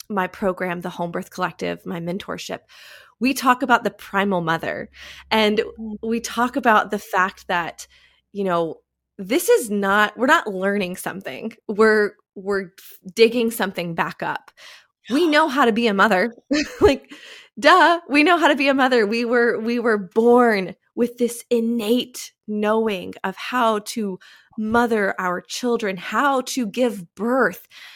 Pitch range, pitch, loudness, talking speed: 195-245 Hz, 220 Hz, -20 LUFS, 150 wpm